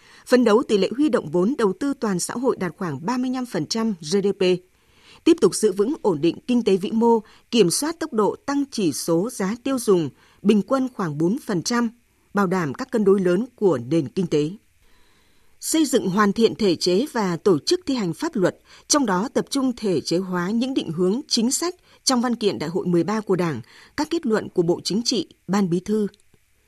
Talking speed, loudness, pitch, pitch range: 210 wpm, -22 LUFS, 210 Hz, 180-250 Hz